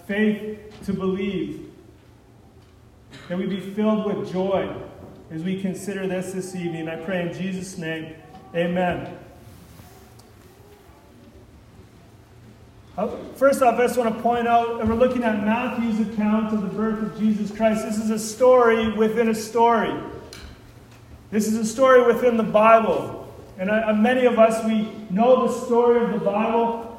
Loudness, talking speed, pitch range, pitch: -21 LUFS, 150 wpm, 165-225 Hz, 210 Hz